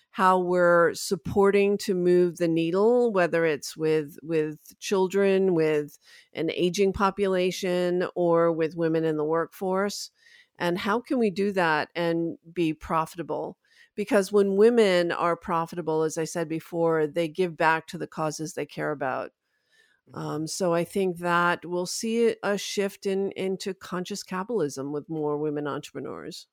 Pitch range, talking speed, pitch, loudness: 160-195 Hz, 150 wpm, 175 Hz, -26 LUFS